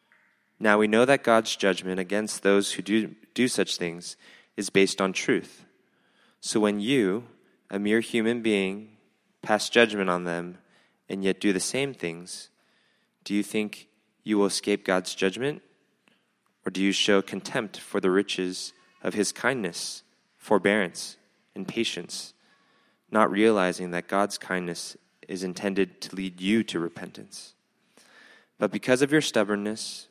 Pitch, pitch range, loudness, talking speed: 100 Hz, 95-110 Hz, -26 LUFS, 145 wpm